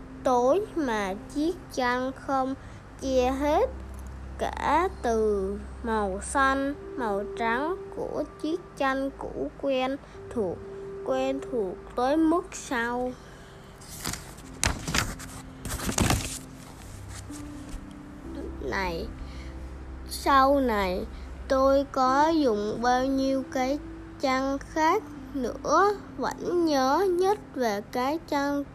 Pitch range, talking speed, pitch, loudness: 205-290 Hz, 90 wpm, 265 Hz, -27 LUFS